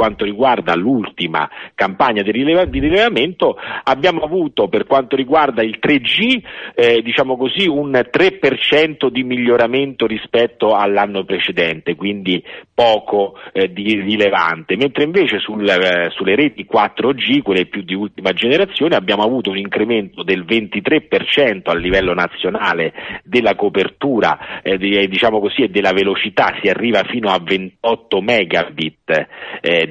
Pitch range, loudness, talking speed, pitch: 95-130 Hz, -15 LUFS, 130 wpm, 105 Hz